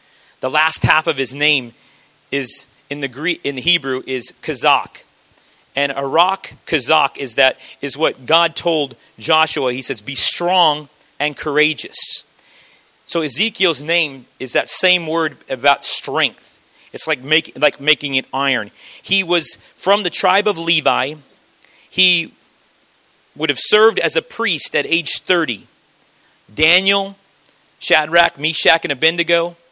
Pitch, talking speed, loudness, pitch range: 155 Hz, 140 wpm, -16 LUFS, 140-170 Hz